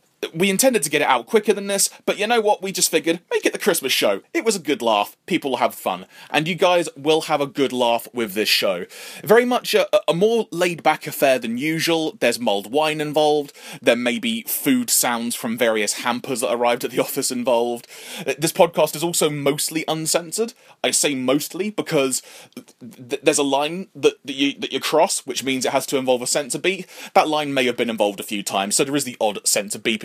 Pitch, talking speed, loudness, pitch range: 155 Hz, 230 wpm, -20 LUFS, 135-195 Hz